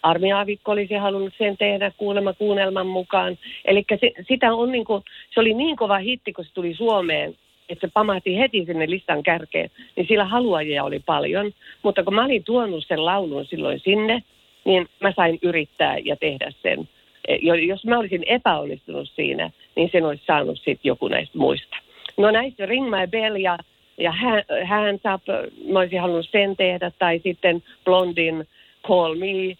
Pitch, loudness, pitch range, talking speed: 195 Hz, -21 LUFS, 180-210 Hz, 170 wpm